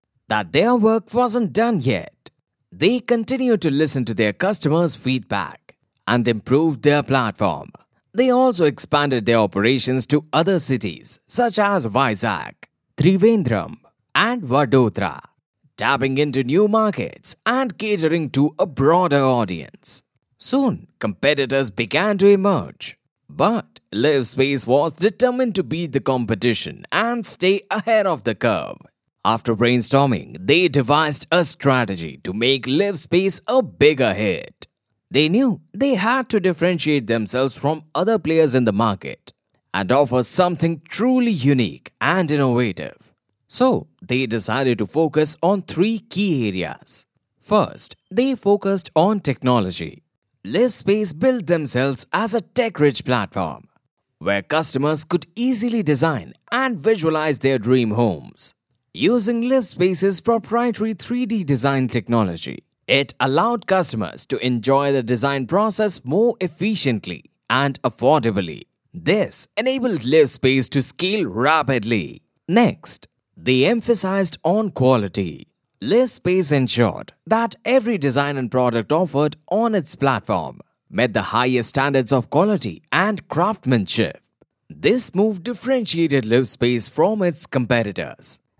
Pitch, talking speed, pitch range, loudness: 150 Hz, 120 wpm, 125-205 Hz, -19 LUFS